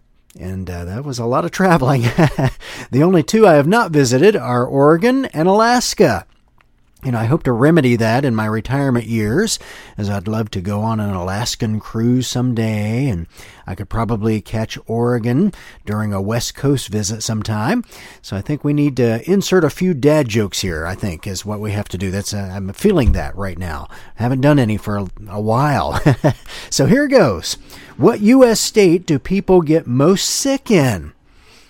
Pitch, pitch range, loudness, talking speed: 120 Hz, 105-150 Hz, -16 LUFS, 185 wpm